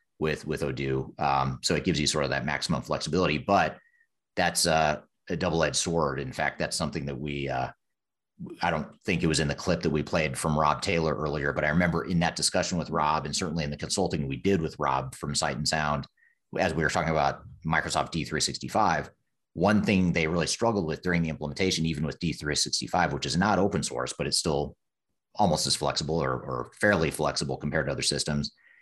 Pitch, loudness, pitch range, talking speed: 80 Hz, -27 LUFS, 70-85 Hz, 210 wpm